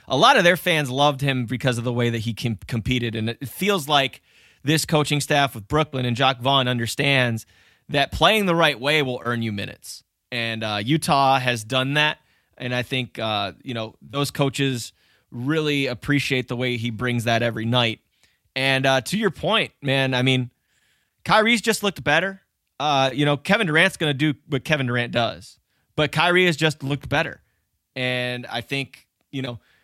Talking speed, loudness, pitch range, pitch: 190 wpm, -21 LUFS, 120-150 Hz, 135 Hz